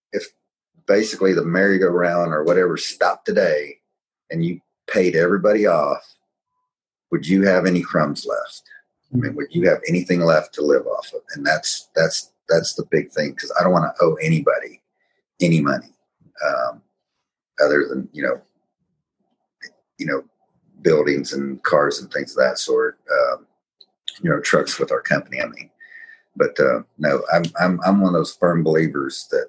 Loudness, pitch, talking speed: -20 LUFS, 95 Hz, 165 wpm